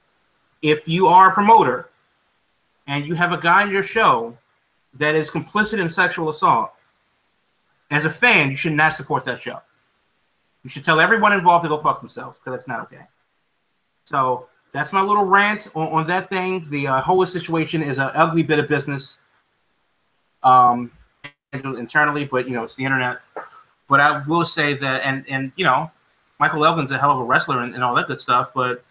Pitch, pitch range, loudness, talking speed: 155 Hz, 135-180 Hz, -18 LUFS, 190 wpm